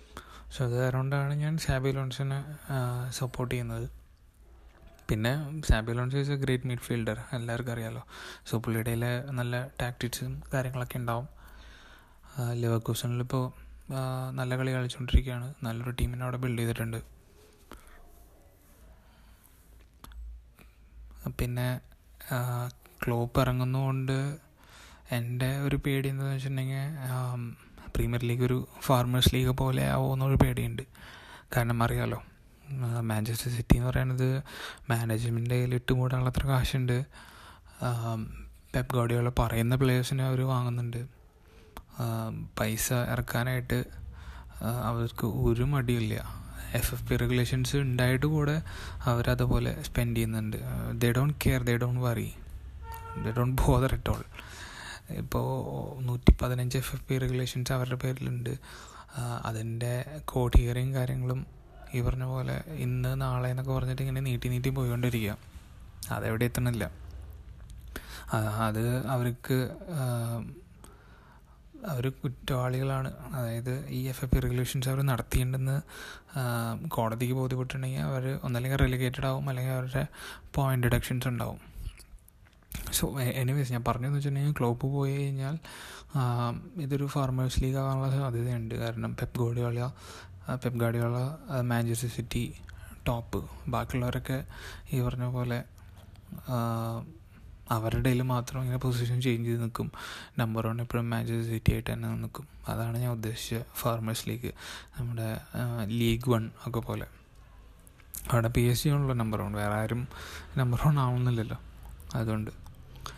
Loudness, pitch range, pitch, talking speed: -31 LUFS, 115-130 Hz, 125 Hz, 105 wpm